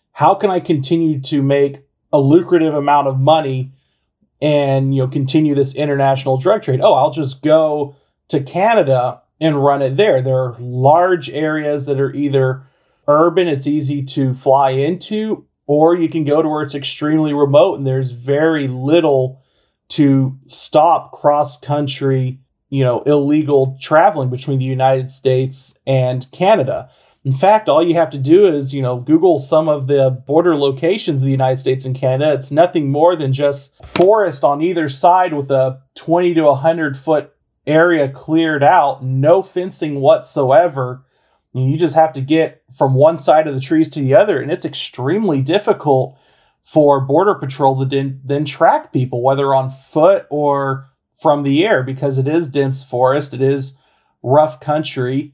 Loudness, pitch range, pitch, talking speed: -15 LUFS, 135-155 Hz, 145 Hz, 165 wpm